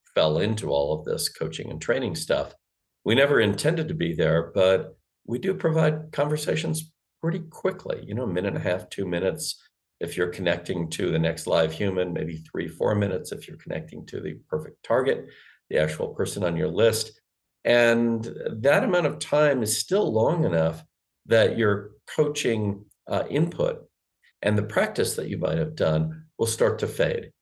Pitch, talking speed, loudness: 105 Hz, 180 wpm, -25 LUFS